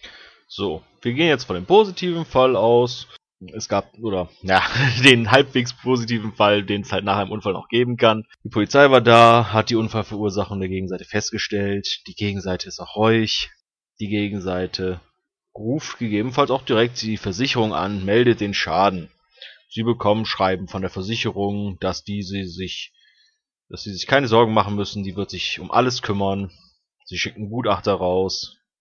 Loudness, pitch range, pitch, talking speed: -20 LUFS, 100-120 Hz, 105 Hz, 165 wpm